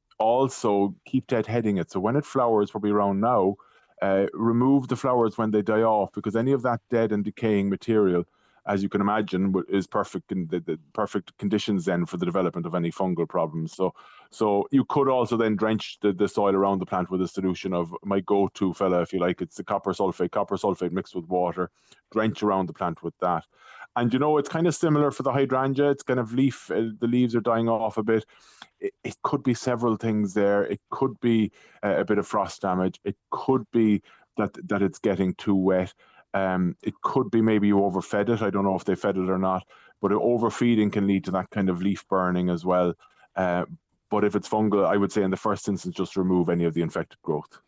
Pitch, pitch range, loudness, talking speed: 105 Hz, 95-115 Hz, -25 LUFS, 225 wpm